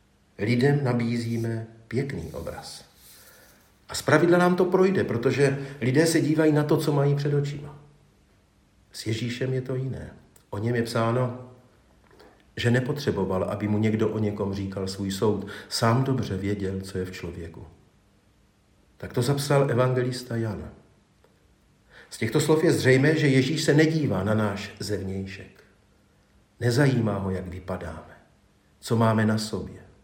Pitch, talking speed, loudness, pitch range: 115 Hz, 140 wpm, -25 LUFS, 100-140 Hz